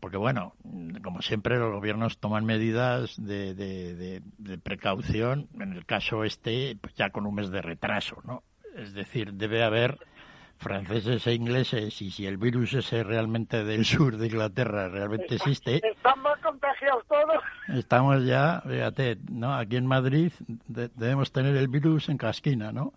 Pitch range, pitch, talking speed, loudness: 105-135 Hz, 115 Hz, 160 wpm, -28 LUFS